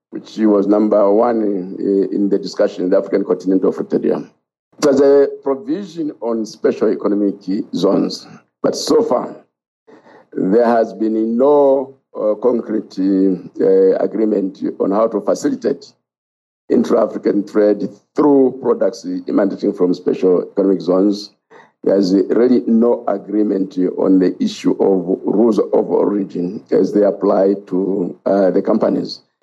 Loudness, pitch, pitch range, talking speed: -16 LUFS, 100 Hz, 95-120 Hz, 125 wpm